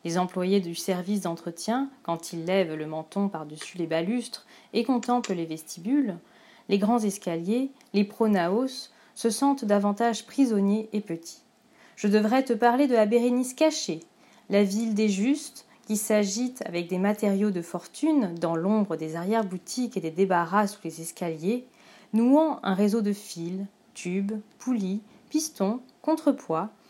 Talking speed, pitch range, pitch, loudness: 145 wpm, 180-240 Hz, 210 Hz, -27 LUFS